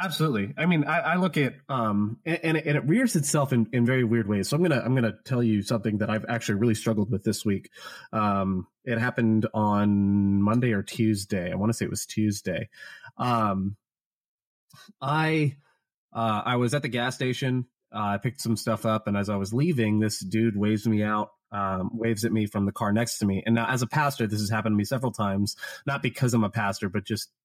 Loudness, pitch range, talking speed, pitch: -26 LUFS, 105-130 Hz, 225 wpm, 115 Hz